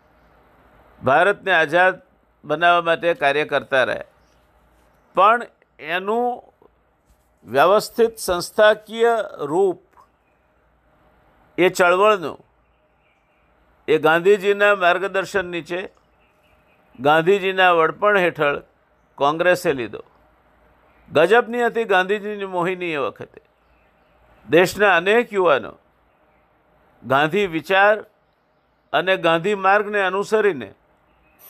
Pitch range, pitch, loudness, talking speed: 170-210 Hz, 190 Hz, -18 LUFS, 70 wpm